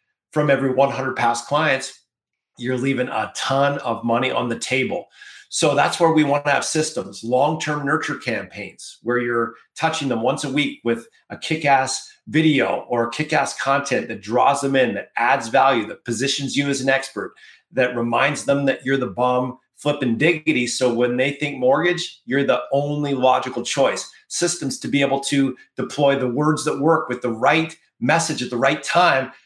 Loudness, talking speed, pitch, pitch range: -20 LUFS, 185 wpm, 135 Hz, 125-150 Hz